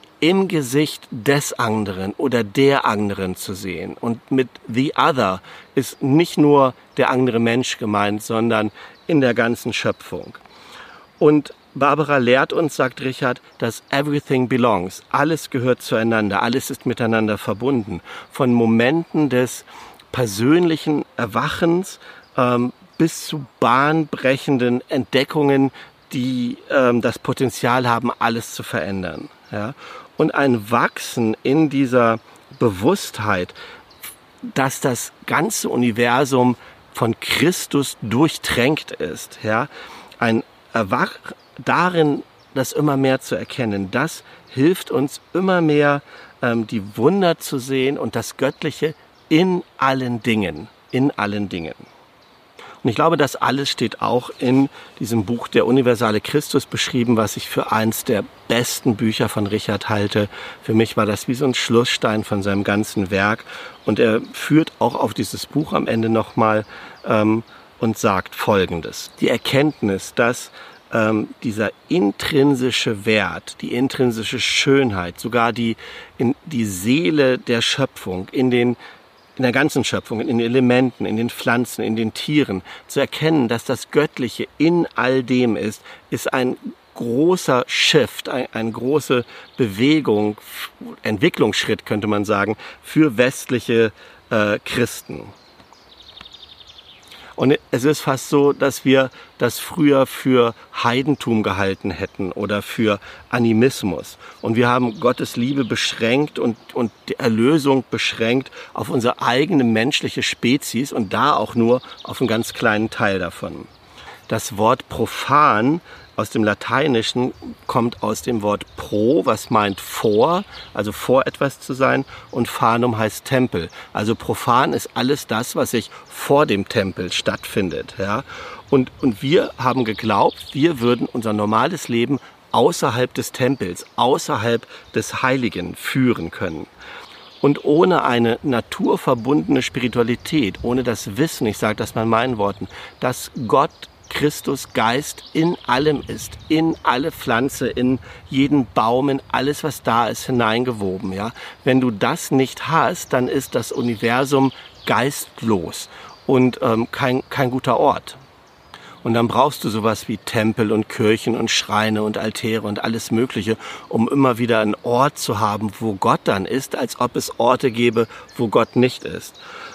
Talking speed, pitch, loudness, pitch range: 140 wpm, 120 Hz, -19 LUFS, 110-135 Hz